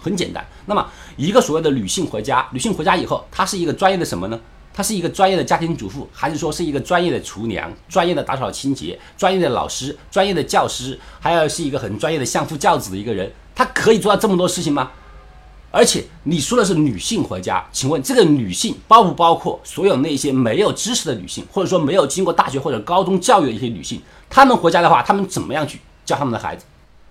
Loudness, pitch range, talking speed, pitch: -18 LUFS, 140-200 Hz, 370 characters per minute, 170 Hz